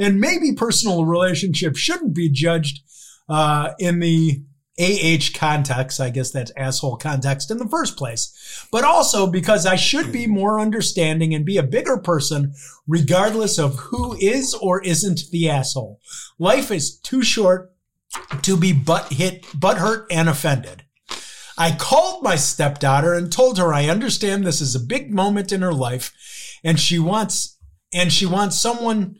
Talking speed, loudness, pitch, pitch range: 155 wpm, -19 LUFS, 170 Hz, 150-200 Hz